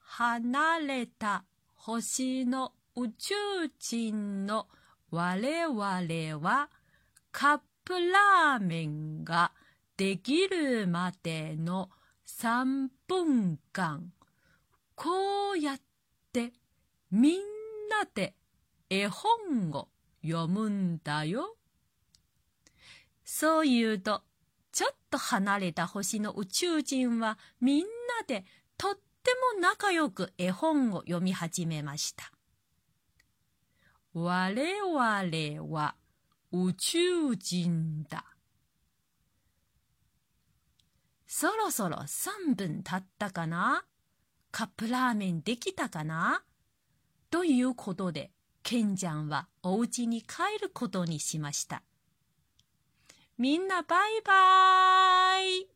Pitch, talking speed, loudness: 230 Hz, 155 characters per minute, -30 LUFS